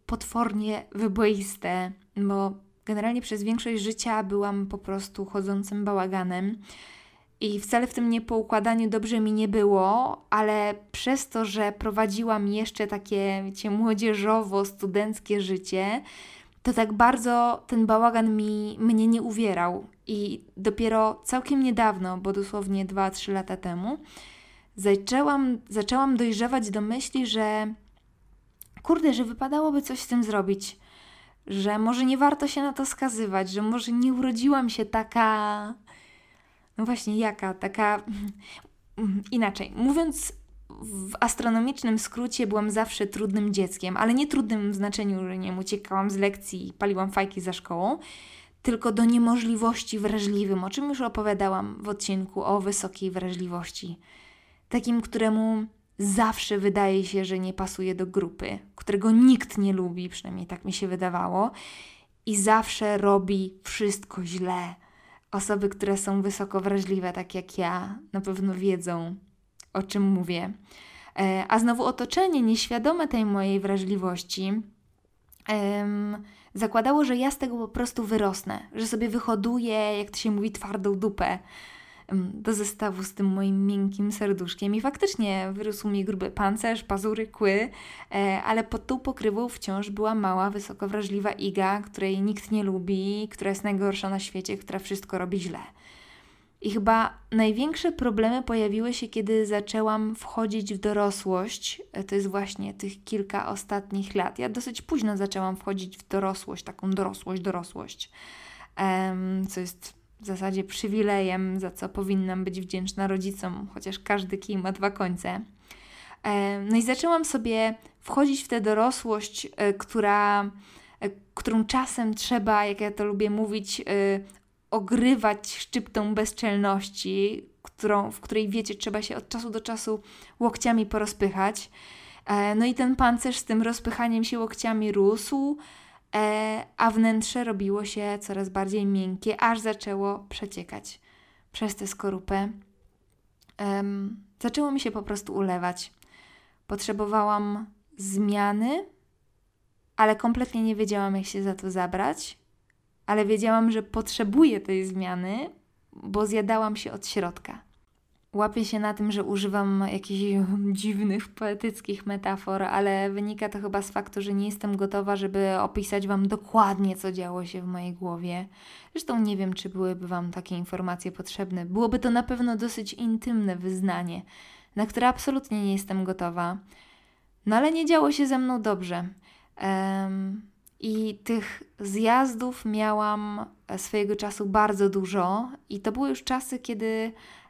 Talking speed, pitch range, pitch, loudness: 135 wpm, 195-225 Hz, 210 Hz, -27 LUFS